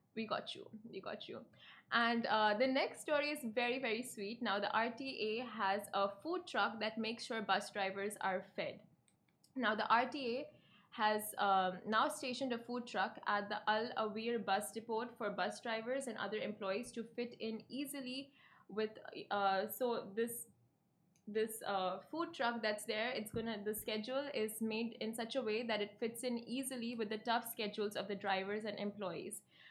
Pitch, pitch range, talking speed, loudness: 220 Hz, 205-240 Hz, 180 wpm, -39 LUFS